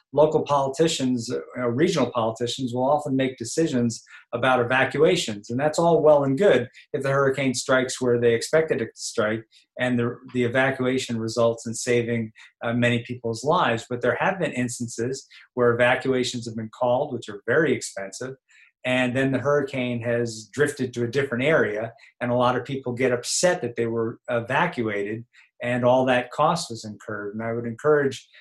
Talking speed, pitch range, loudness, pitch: 175 wpm, 120-135 Hz, -23 LUFS, 125 Hz